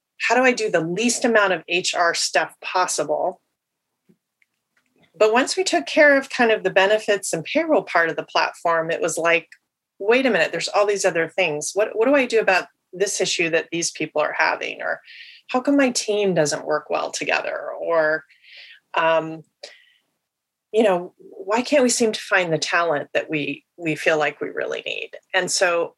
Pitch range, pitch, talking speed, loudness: 165-255 Hz, 200 Hz, 190 wpm, -20 LUFS